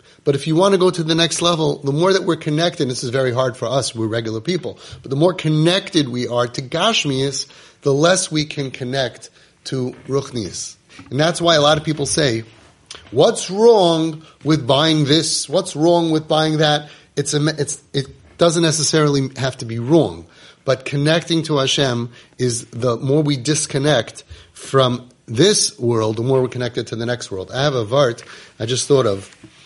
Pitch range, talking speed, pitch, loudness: 125-160 Hz, 195 wpm, 145 Hz, -18 LUFS